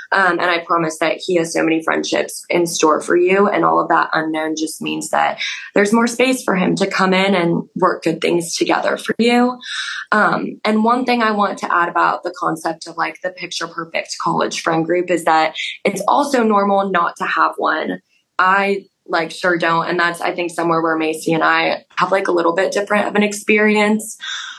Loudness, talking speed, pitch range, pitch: -17 LUFS, 210 wpm, 165-205 Hz, 180 Hz